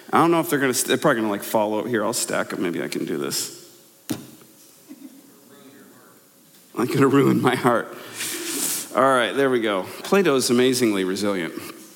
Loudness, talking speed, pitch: -21 LUFS, 165 wpm, 165 Hz